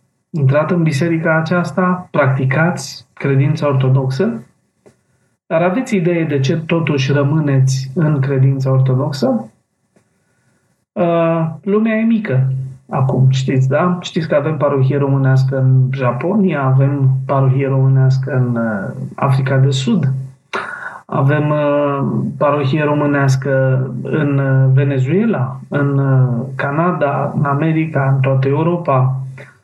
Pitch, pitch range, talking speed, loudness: 140 Hz, 130-160 Hz, 100 wpm, -15 LUFS